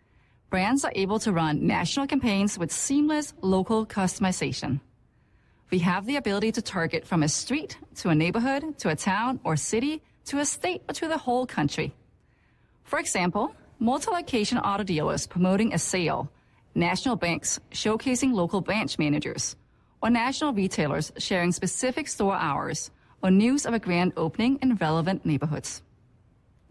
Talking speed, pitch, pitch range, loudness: 150 wpm, 190 Hz, 160-250 Hz, -26 LUFS